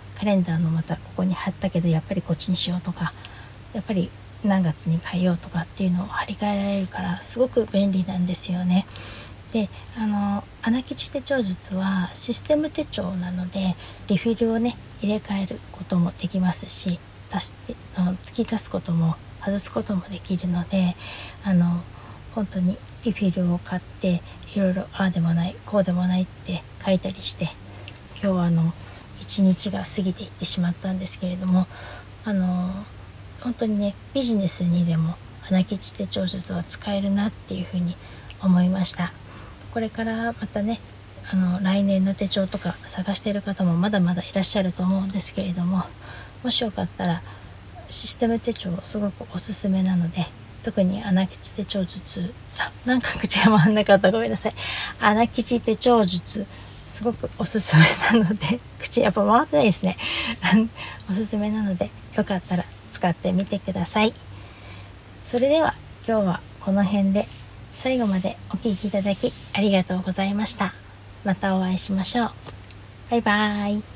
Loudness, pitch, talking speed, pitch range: -23 LUFS, 190 Hz, 320 characters per minute, 175-205 Hz